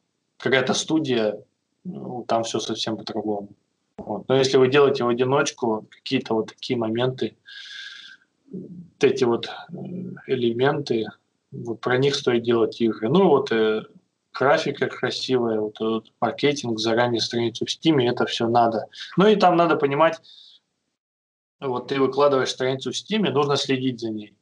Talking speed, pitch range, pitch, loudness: 140 wpm, 115-155 Hz, 130 Hz, -22 LUFS